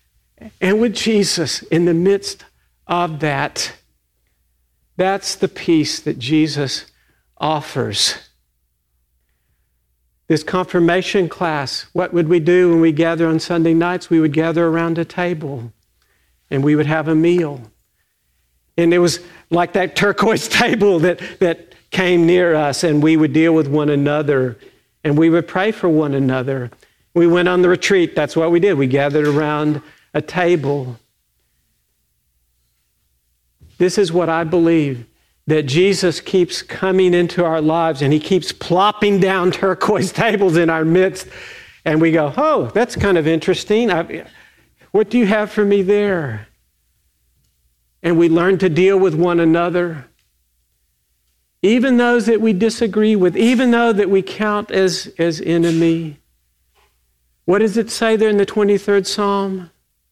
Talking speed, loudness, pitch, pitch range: 150 wpm, -16 LUFS, 165 Hz, 140-190 Hz